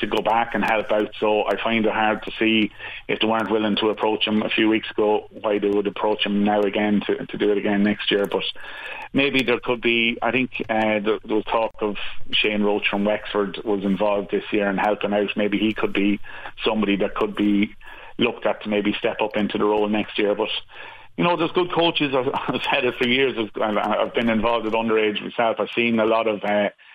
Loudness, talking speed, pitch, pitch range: -21 LUFS, 230 wpm, 105 Hz, 105-110 Hz